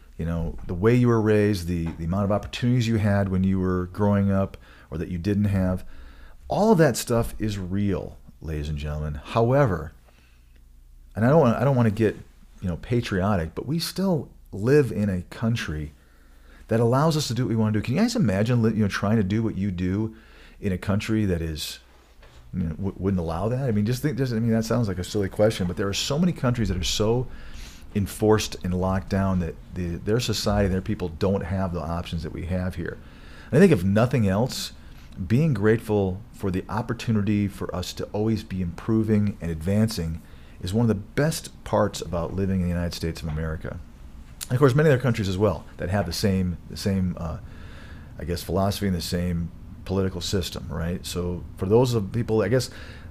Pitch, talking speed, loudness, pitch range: 95 Hz, 215 wpm, -24 LUFS, 85-110 Hz